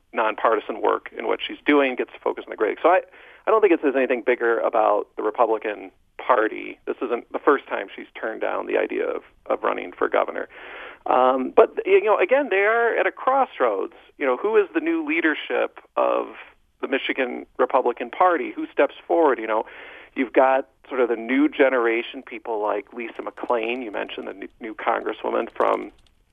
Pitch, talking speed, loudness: 315 Hz, 195 wpm, -22 LUFS